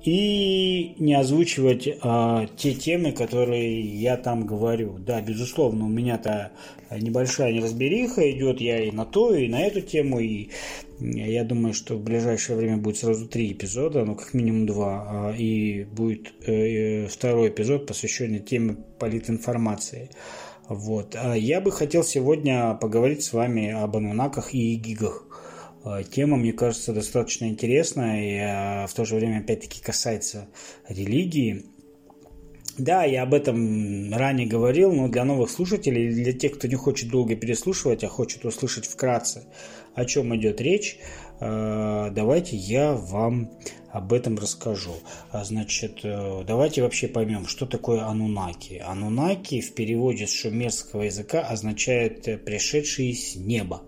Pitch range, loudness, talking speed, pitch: 110-130 Hz, -25 LUFS, 135 wpm, 115 Hz